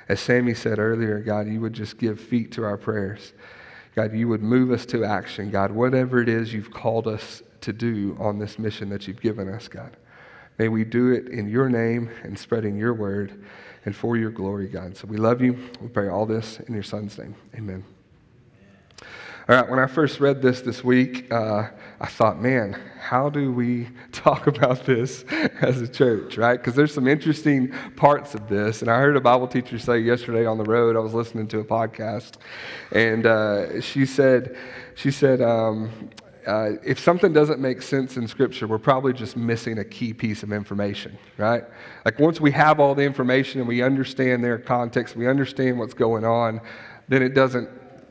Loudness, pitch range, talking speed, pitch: -22 LUFS, 110-125 Hz, 195 wpm, 115 Hz